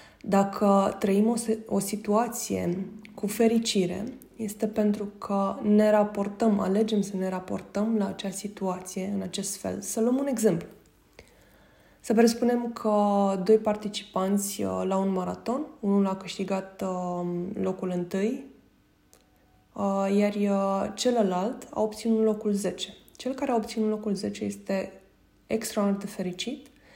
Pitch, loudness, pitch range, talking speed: 205 Hz, -27 LUFS, 195-220 Hz, 120 wpm